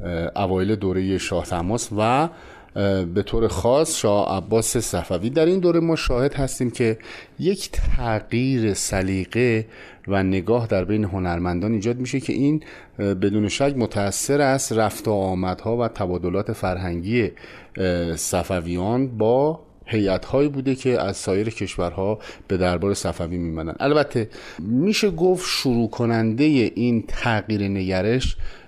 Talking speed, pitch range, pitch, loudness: 125 wpm, 95-125 Hz, 110 Hz, -22 LUFS